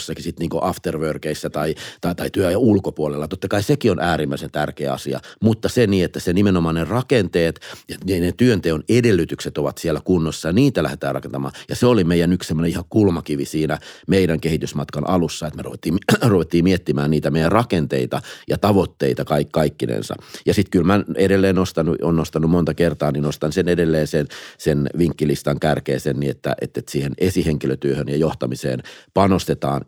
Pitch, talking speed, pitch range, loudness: 80 Hz, 175 wpm, 75-90 Hz, -20 LUFS